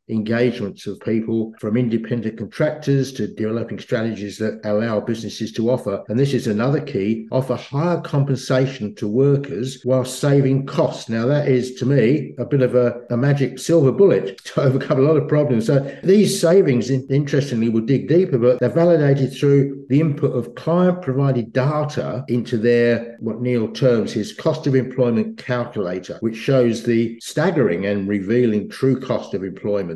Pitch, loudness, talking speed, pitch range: 125 Hz, -19 LUFS, 165 wpm, 115-140 Hz